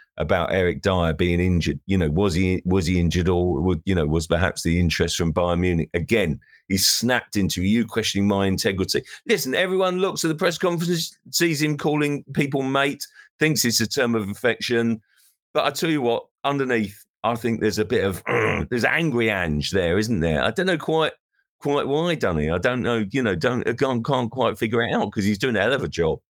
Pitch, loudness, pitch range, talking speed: 110 Hz, -22 LUFS, 90-140 Hz, 210 wpm